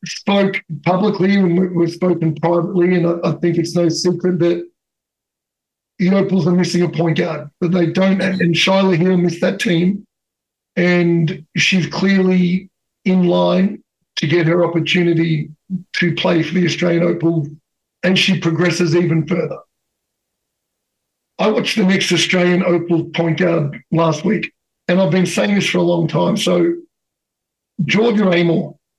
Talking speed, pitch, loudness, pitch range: 150 wpm, 175 Hz, -16 LUFS, 165-185 Hz